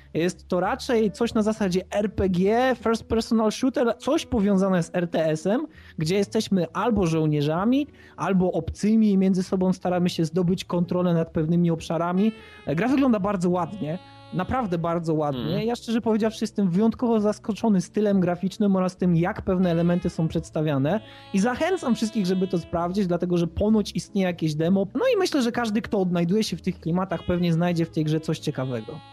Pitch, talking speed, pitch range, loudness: 190 Hz, 170 wpm, 170-220 Hz, -24 LUFS